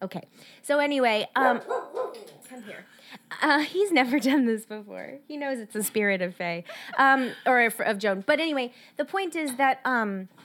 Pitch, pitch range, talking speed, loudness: 255 Hz, 215-290 Hz, 170 wpm, -25 LUFS